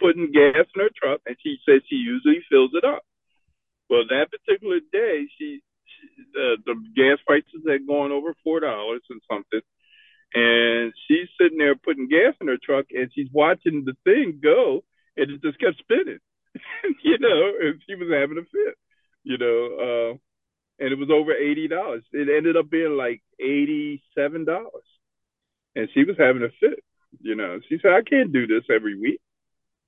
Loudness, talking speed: -22 LUFS, 185 wpm